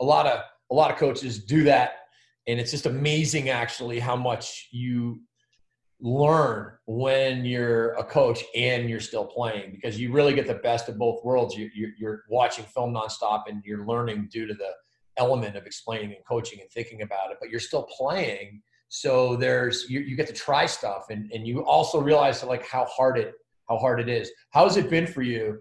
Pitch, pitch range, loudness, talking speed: 120 Hz, 110-130 Hz, -25 LUFS, 205 wpm